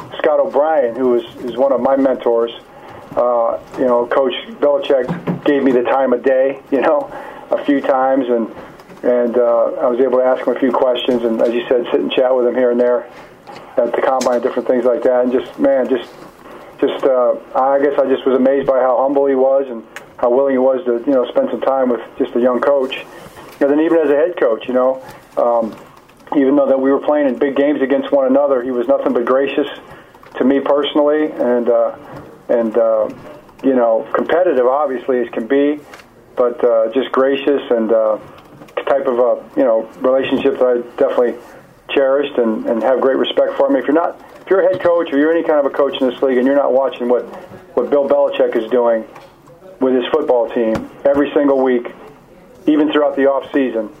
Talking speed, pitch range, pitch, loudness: 220 wpm, 120-140 Hz, 135 Hz, -15 LUFS